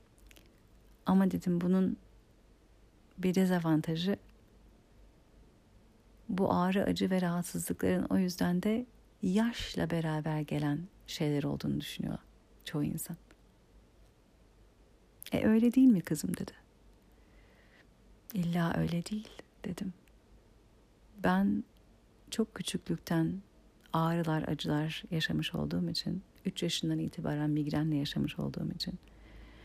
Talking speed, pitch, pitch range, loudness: 95 wpm, 165 Hz, 150-190 Hz, -33 LUFS